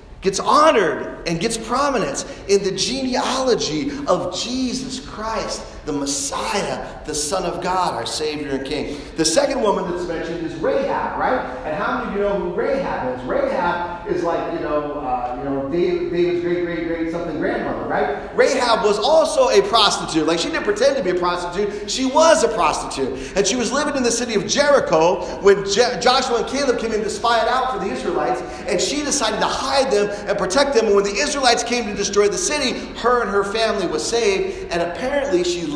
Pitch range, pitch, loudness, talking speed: 175-260 Hz, 205 Hz, -19 LUFS, 200 wpm